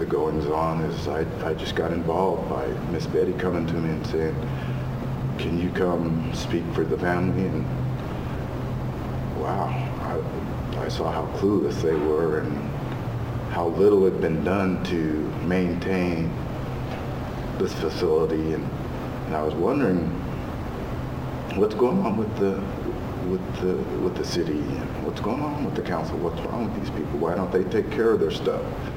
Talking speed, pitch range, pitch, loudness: 160 wpm, 80-95 Hz, 85 Hz, -26 LUFS